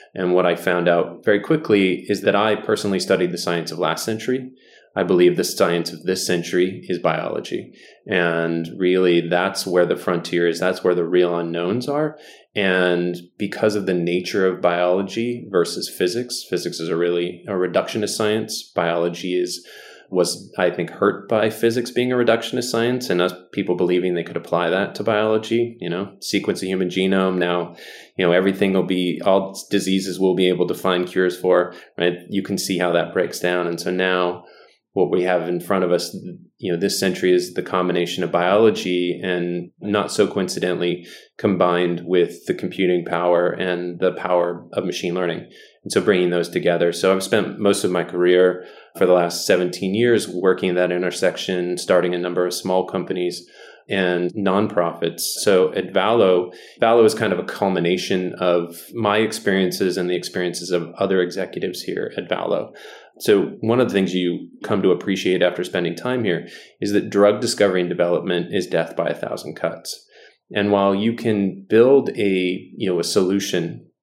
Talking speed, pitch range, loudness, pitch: 180 wpm, 90-100 Hz, -20 LUFS, 90 Hz